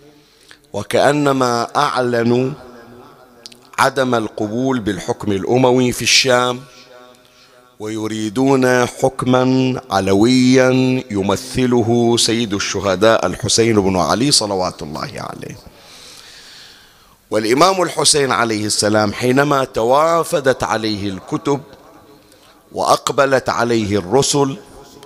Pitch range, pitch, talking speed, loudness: 110-130 Hz, 125 Hz, 75 wpm, -15 LUFS